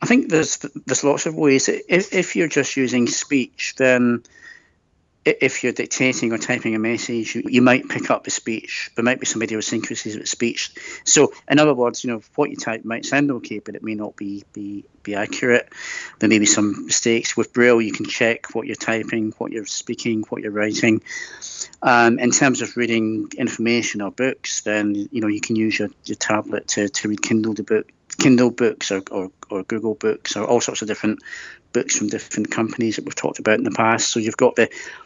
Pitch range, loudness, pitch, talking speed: 105-125 Hz, -20 LUFS, 115 Hz, 210 wpm